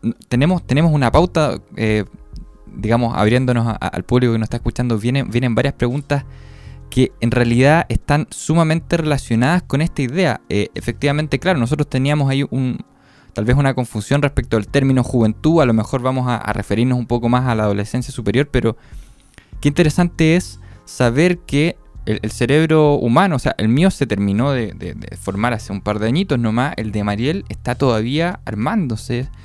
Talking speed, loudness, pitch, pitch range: 180 wpm, -17 LUFS, 125 Hz, 110-145 Hz